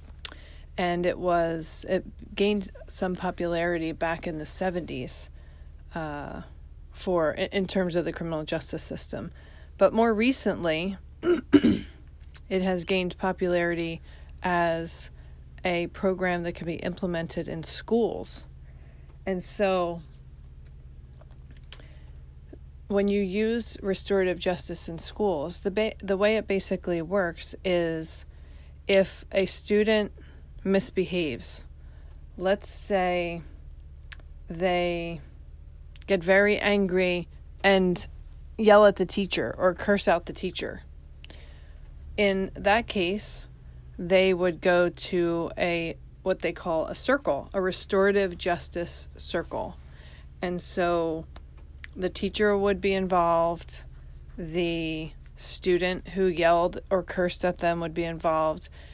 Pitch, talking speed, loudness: 170 Hz, 110 wpm, -26 LUFS